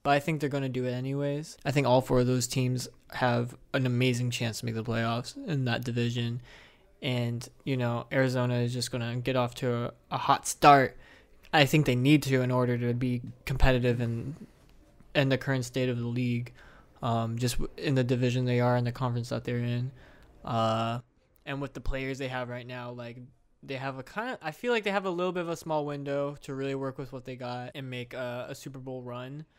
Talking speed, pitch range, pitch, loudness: 230 wpm, 120-140 Hz, 125 Hz, -29 LUFS